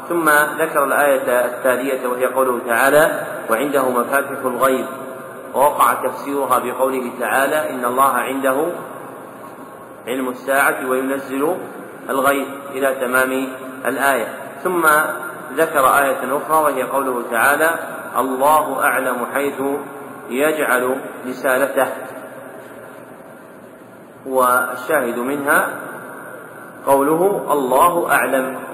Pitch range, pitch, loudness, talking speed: 125-140 Hz, 135 Hz, -18 LUFS, 85 wpm